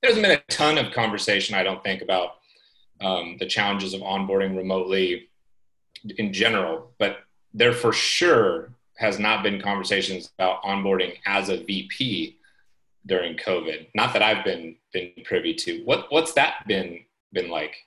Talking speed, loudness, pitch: 155 wpm, -23 LUFS, 100 Hz